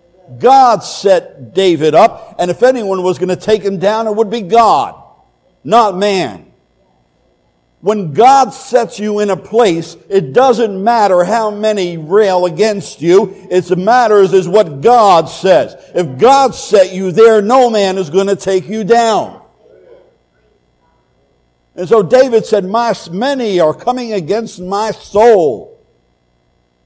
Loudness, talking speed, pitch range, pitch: -11 LUFS, 145 wpm, 175-225 Hz, 195 Hz